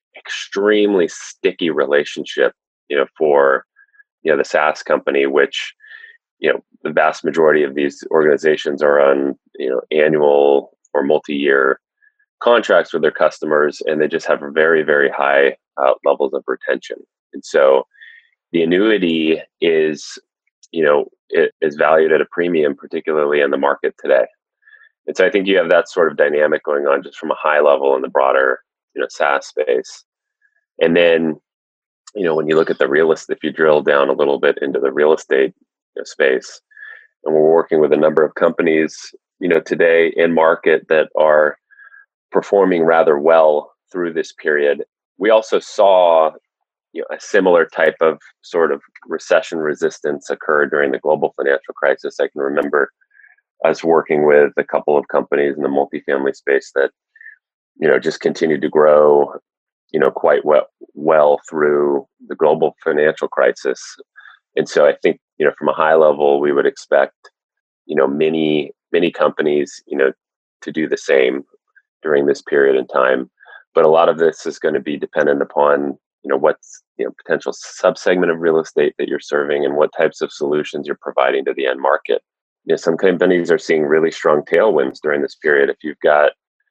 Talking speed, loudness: 180 wpm, -16 LUFS